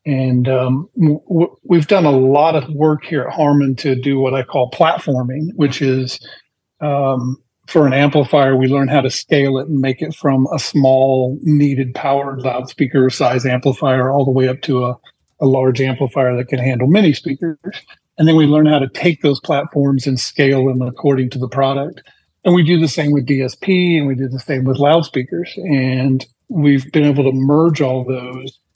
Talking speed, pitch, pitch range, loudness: 195 wpm, 140 Hz, 130-150 Hz, -15 LUFS